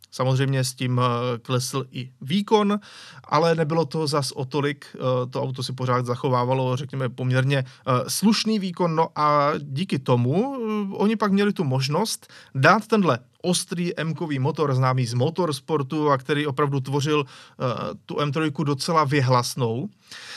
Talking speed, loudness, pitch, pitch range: 135 wpm, -23 LUFS, 145 Hz, 130-165 Hz